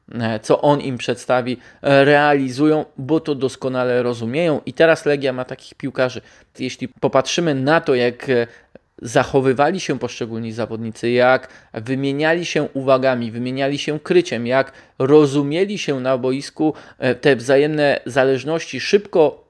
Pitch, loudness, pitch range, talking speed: 135 Hz, -18 LUFS, 125-150 Hz, 125 wpm